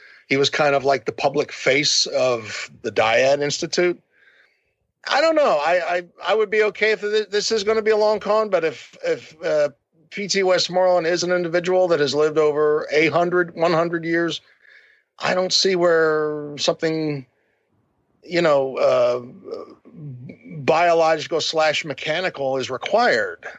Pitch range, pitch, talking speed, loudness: 150-200 Hz, 170 Hz, 155 wpm, -20 LUFS